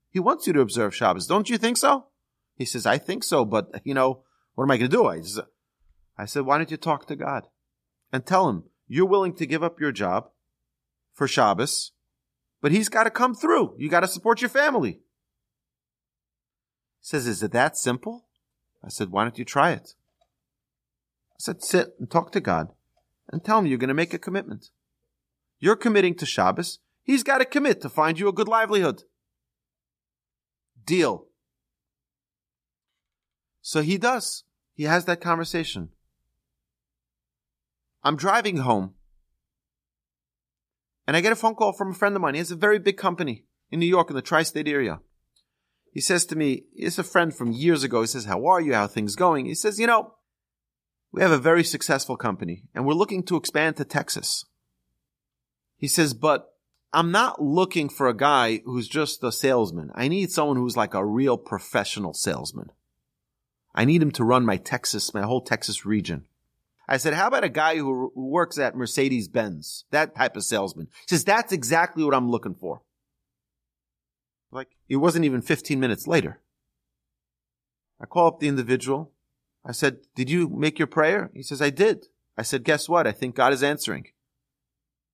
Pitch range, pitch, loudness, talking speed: 110-175 Hz, 140 Hz, -23 LUFS, 180 wpm